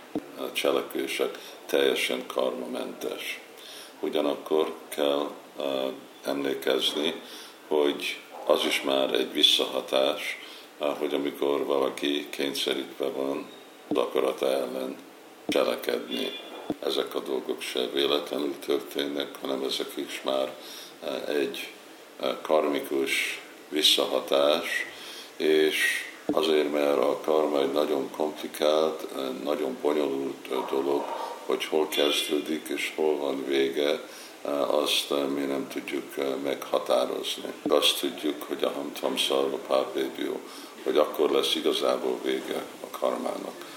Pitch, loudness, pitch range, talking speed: 70 Hz, -27 LUFS, 70-75 Hz, 95 wpm